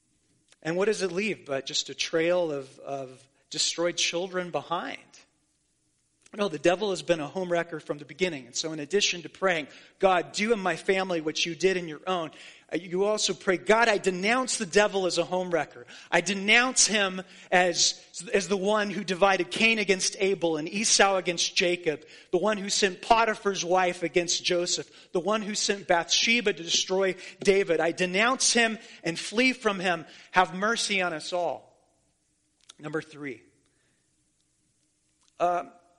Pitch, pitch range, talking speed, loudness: 180 Hz, 170-200 Hz, 170 wpm, -26 LUFS